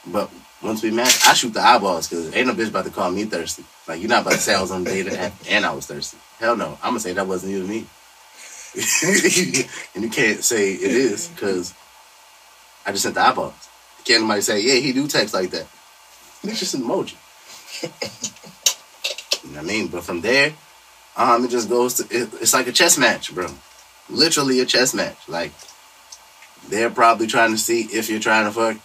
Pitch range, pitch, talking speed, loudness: 110-125 Hz, 115 Hz, 210 wpm, -19 LUFS